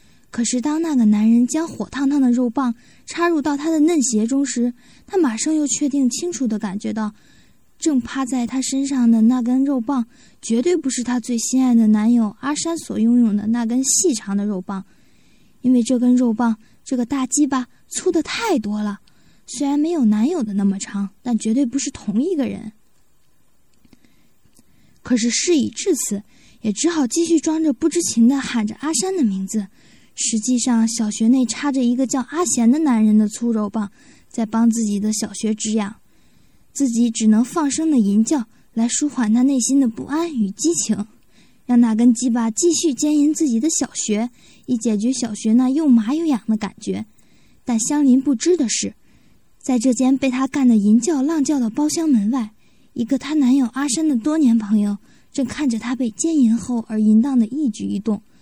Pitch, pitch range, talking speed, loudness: 250 Hz, 225-285 Hz, 265 characters per minute, -19 LUFS